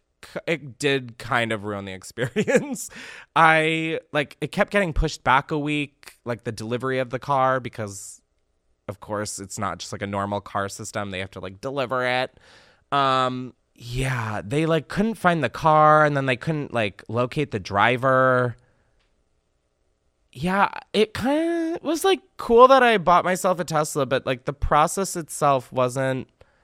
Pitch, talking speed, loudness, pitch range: 130 Hz, 165 wpm, -22 LUFS, 105-160 Hz